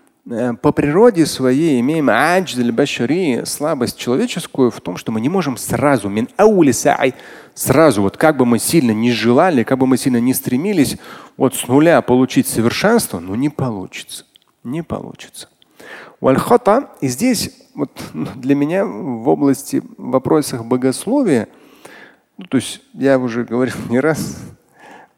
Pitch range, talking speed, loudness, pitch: 120-160 Hz, 135 wpm, -16 LUFS, 135 Hz